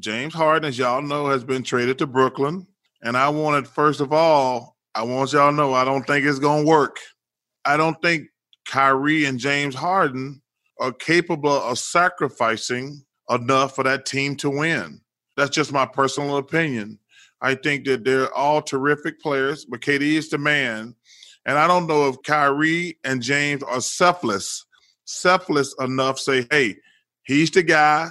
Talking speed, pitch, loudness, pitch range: 165 wpm, 140 Hz, -20 LUFS, 130-155 Hz